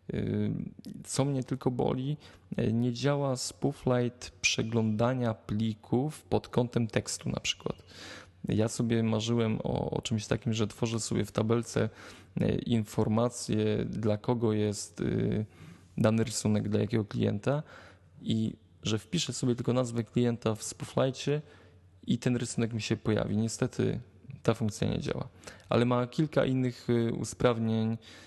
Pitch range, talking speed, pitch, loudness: 110-125 Hz, 125 wpm, 115 Hz, -31 LUFS